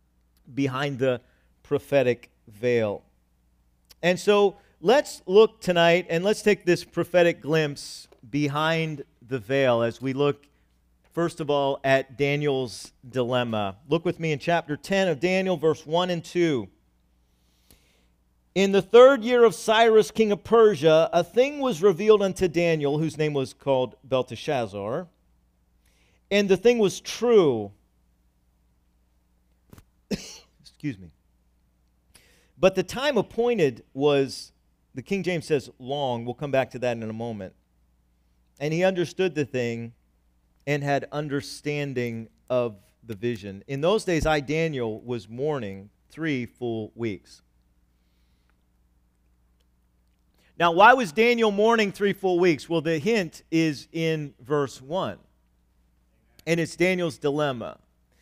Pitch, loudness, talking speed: 135 Hz, -24 LUFS, 130 wpm